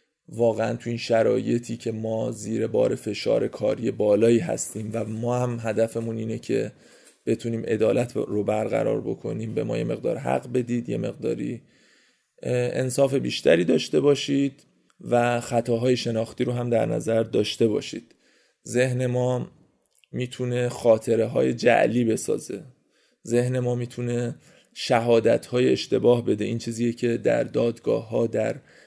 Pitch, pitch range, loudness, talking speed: 120 Hz, 115-125 Hz, -24 LUFS, 135 wpm